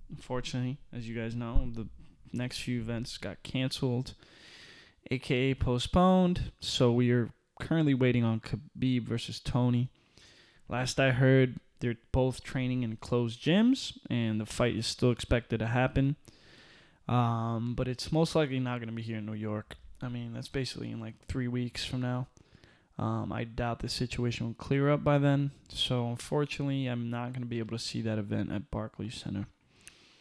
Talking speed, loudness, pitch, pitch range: 175 wpm, -31 LUFS, 125 Hz, 115-130 Hz